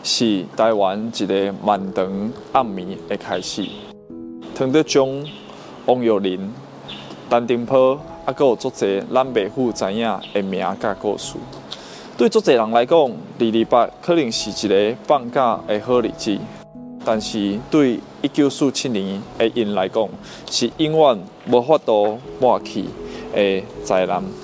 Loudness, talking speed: -19 LUFS, 195 characters per minute